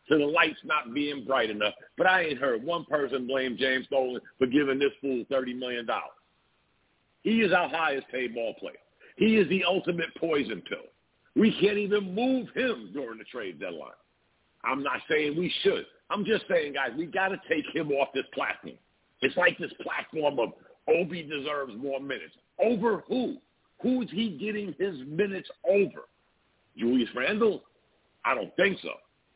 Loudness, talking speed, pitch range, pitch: -28 LUFS, 175 wpm, 135-200 Hz, 155 Hz